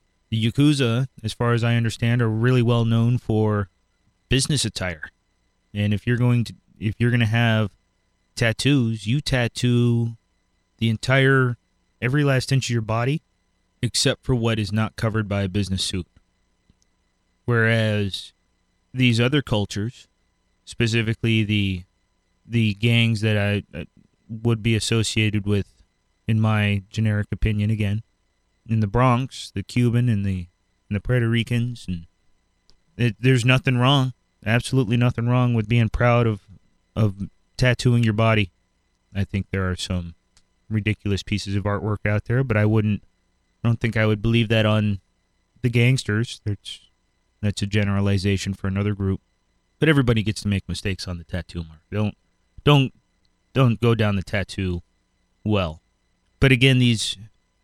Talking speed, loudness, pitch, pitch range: 150 wpm, -22 LUFS, 110 Hz, 95-120 Hz